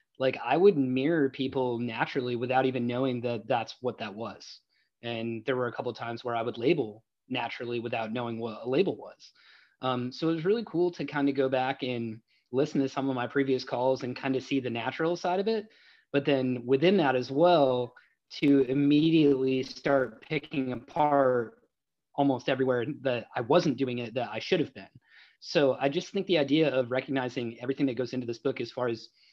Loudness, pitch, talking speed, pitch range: -29 LUFS, 130 Hz, 205 wpm, 120-140 Hz